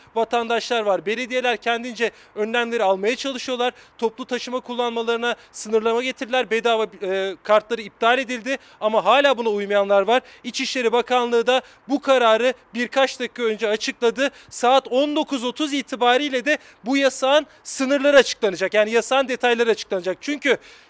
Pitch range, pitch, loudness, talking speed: 225-260 Hz, 240 Hz, -21 LUFS, 125 wpm